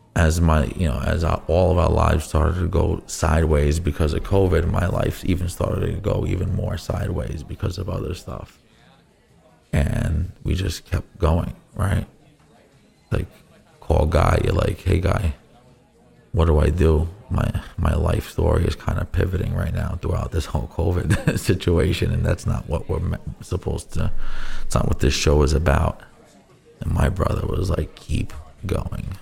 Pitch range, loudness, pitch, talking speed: 80-100 Hz, -22 LUFS, 90 Hz, 170 wpm